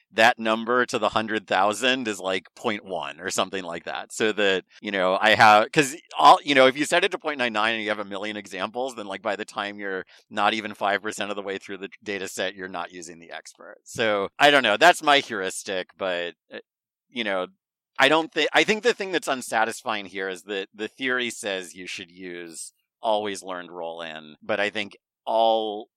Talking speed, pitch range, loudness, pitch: 220 wpm, 95-115 Hz, -23 LUFS, 105 Hz